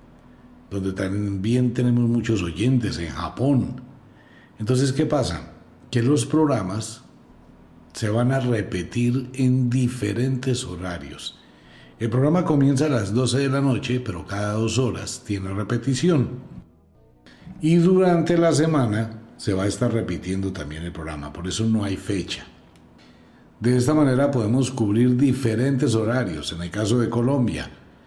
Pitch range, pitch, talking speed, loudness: 95-130 Hz, 120 Hz, 135 wpm, -22 LUFS